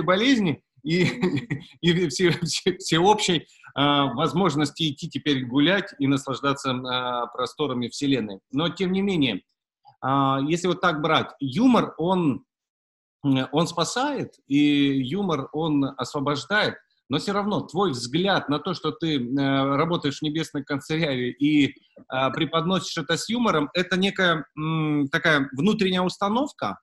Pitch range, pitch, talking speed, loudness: 140-180 Hz, 155 Hz, 130 wpm, -24 LUFS